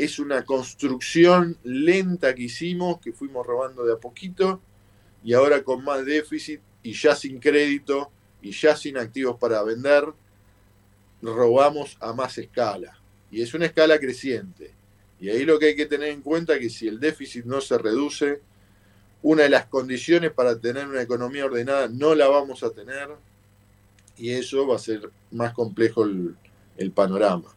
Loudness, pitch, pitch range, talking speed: -23 LUFS, 125 Hz, 100-145 Hz, 170 wpm